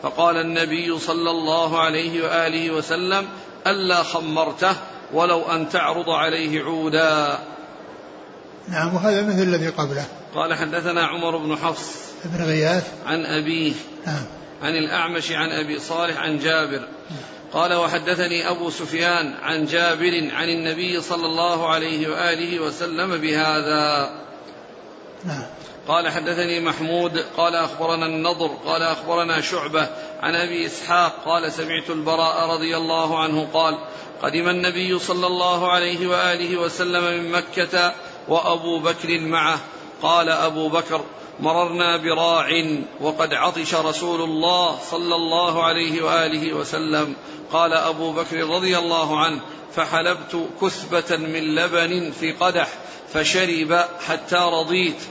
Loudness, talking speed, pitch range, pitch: -21 LUFS, 120 wpm, 160-175 Hz, 165 Hz